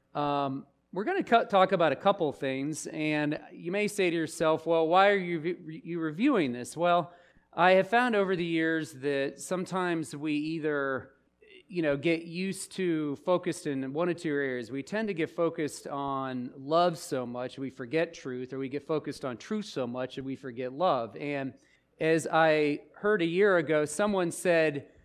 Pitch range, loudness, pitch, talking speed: 140-180 Hz, -29 LUFS, 160 Hz, 185 wpm